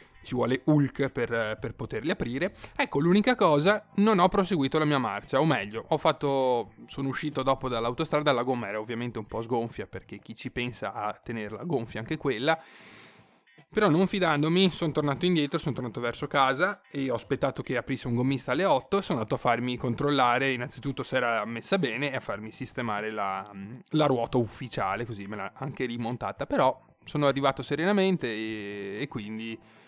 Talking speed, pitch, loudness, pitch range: 180 wpm, 130 Hz, -28 LUFS, 115-150 Hz